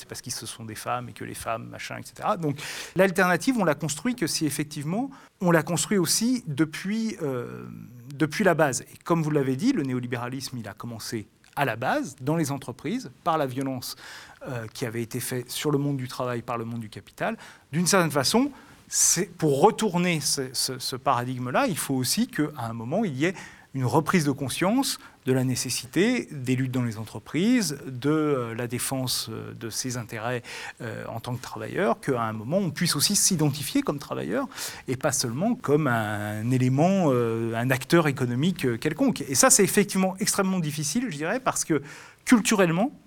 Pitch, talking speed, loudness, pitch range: 145 Hz, 190 wpm, -25 LUFS, 125-185 Hz